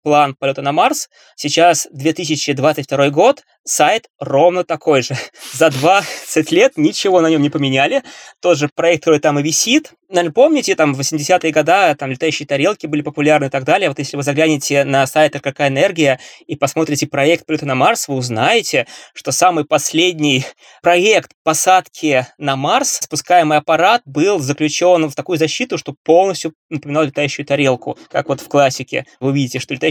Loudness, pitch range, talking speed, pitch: -15 LUFS, 140-170 Hz, 165 wpm, 155 Hz